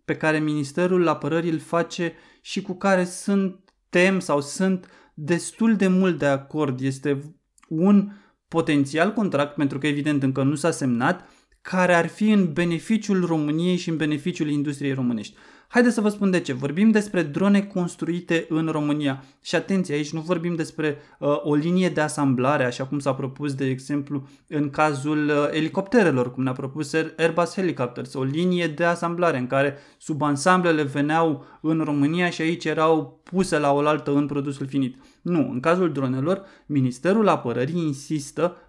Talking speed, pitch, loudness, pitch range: 160 wpm, 155 Hz, -23 LUFS, 145-175 Hz